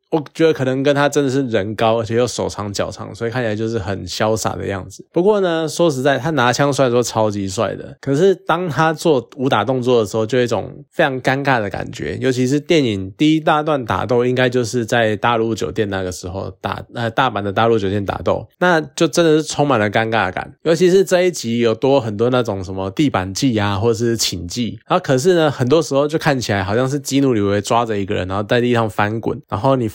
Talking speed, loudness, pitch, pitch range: 350 characters per minute, -17 LUFS, 120 Hz, 110-145 Hz